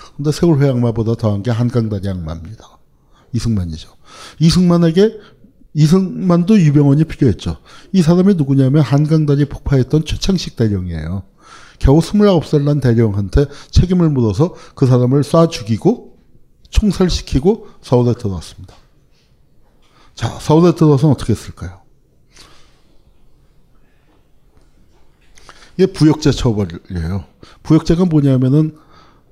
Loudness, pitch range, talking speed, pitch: -14 LUFS, 105-165 Hz, 275 characters per minute, 140 Hz